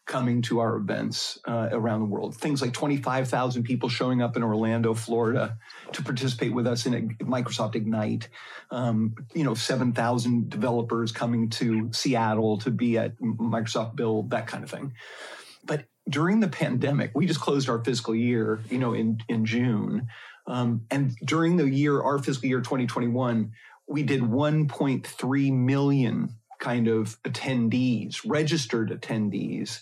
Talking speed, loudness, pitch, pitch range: 150 wpm, -26 LUFS, 120 Hz, 115-135 Hz